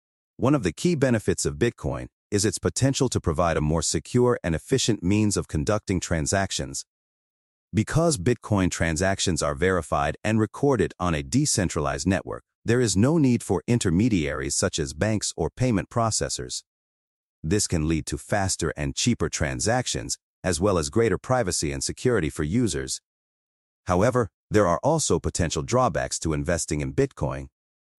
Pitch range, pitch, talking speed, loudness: 75-115 Hz, 90 Hz, 150 wpm, -24 LUFS